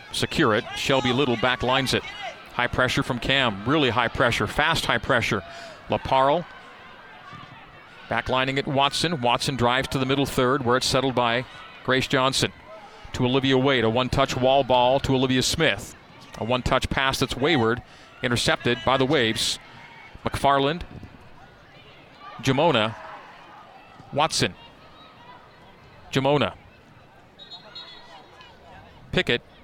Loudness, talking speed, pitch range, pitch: -23 LUFS, 120 wpm, 120-135 Hz, 130 Hz